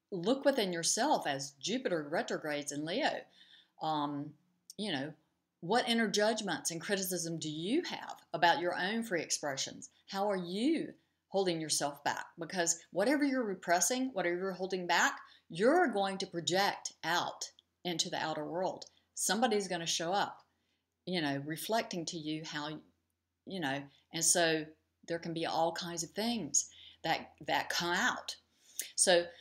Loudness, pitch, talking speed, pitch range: -34 LUFS, 175 Hz, 150 wpm, 160-200 Hz